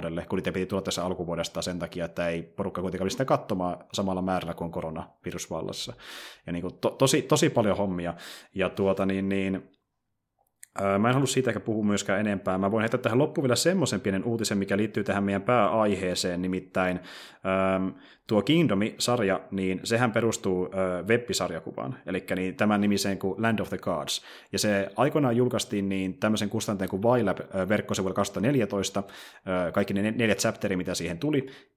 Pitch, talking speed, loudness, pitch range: 100 Hz, 160 wpm, -27 LUFS, 95-110 Hz